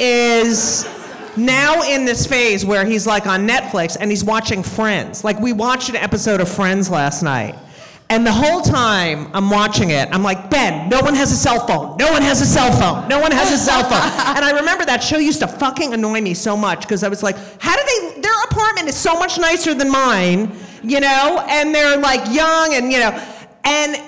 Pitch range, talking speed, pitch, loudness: 205-285 Hz, 220 wpm, 235 Hz, -15 LUFS